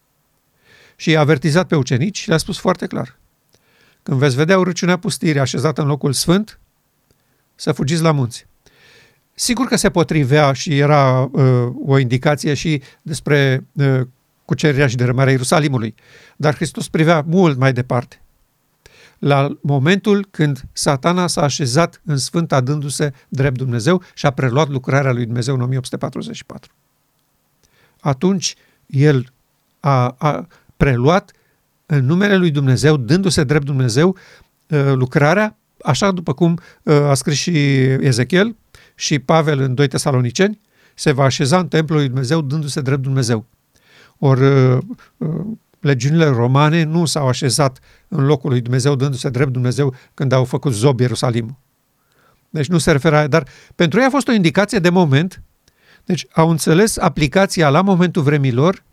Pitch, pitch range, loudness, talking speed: 150 Hz, 135-170 Hz, -16 LUFS, 140 wpm